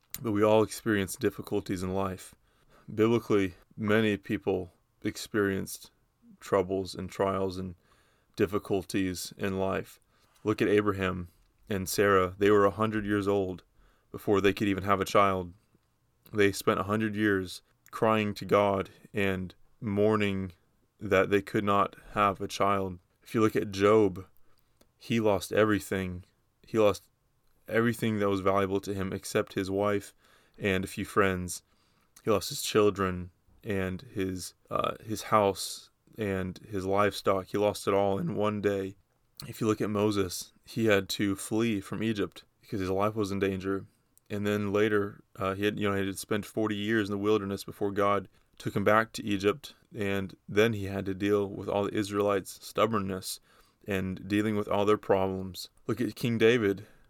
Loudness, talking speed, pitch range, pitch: -29 LUFS, 165 wpm, 95-105 Hz, 100 Hz